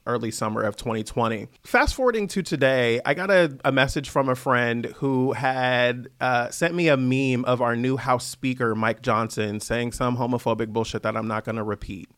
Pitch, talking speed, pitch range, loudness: 125 Hz, 195 wpm, 115-135 Hz, -23 LUFS